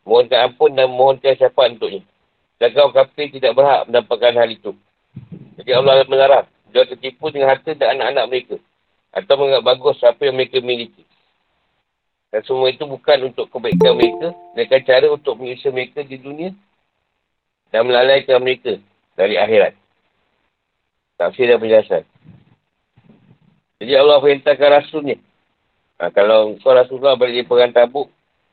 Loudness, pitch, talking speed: -15 LUFS, 140 Hz, 145 wpm